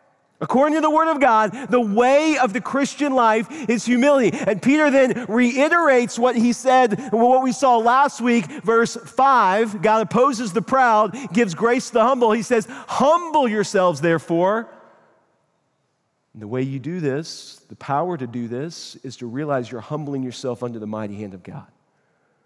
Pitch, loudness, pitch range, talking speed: 230 Hz, -19 LUFS, 160-255 Hz, 175 wpm